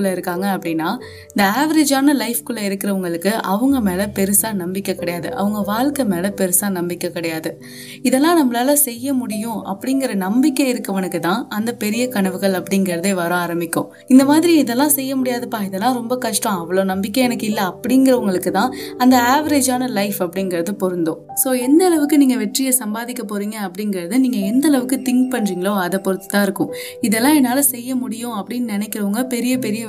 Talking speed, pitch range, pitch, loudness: 150 wpm, 190-255 Hz, 215 Hz, -18 LUFS